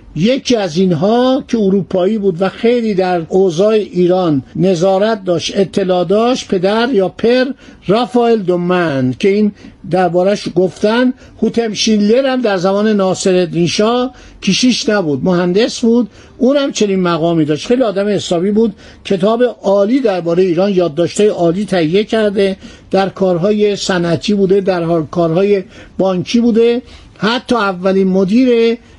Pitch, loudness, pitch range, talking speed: 200 Hz, -13 LUFS, 180-230 Hz, 130 wpm